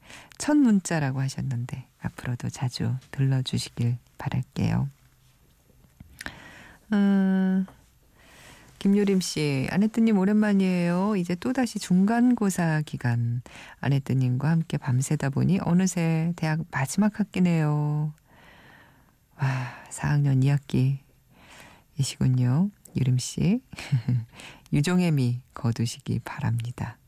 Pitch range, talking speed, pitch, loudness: 130-185 Hz, 215 characters per minute, 150 Hz, -26 LUFS